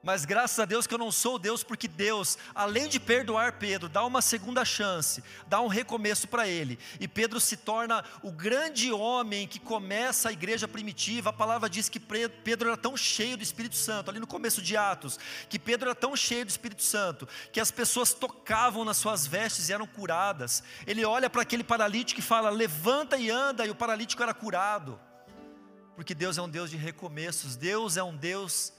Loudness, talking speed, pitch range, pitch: -29 LUFS, 200 wpm, 195-235 Hz, 220 Hz